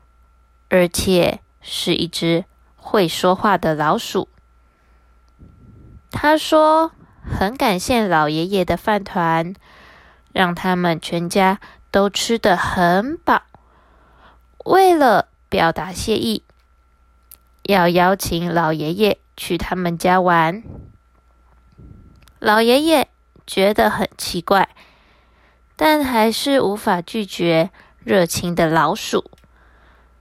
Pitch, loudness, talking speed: 175 Hz, -18 LUFS, 135 characters per minute